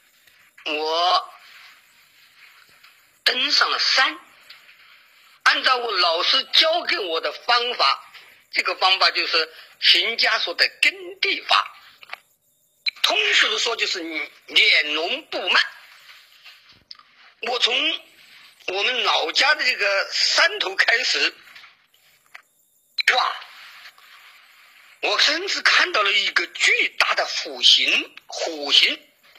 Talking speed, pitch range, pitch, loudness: 140 characters per minute, 240-360 Hz, 295 Hz, -18 LUFS